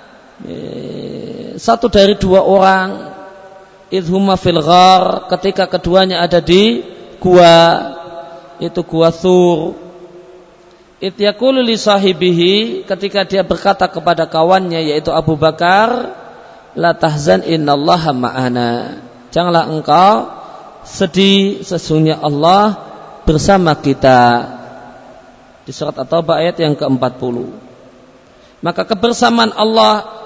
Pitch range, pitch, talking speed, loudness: 160-195 Hz, 175 Hz, 85 wpm, -12 LUFS